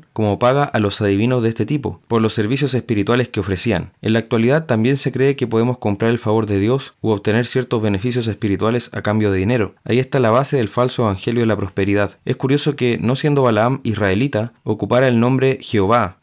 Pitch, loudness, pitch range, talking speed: 115 Hz, -17 LUFS, 105-125 Hz, 210 wpm